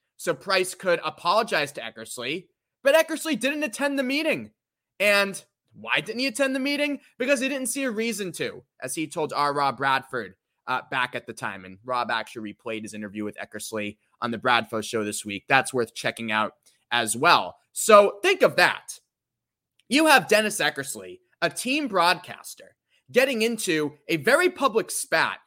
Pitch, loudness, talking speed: 200 Hz, -24 LUFS, 175 wpm